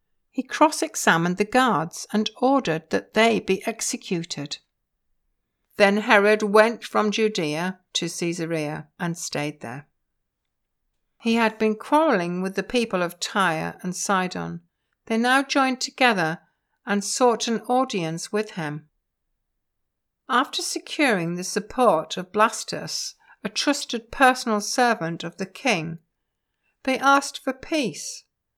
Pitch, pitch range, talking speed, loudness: 210 Hz, 175-255 Hz, 125 wpm, -23 LUFS